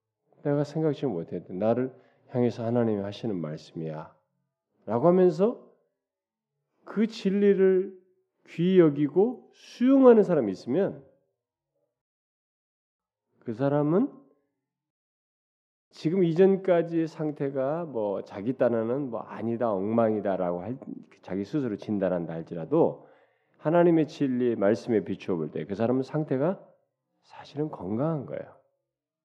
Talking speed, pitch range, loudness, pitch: 245 characters per minute, 115-180 Hz, -26 LUFS, 145 Hz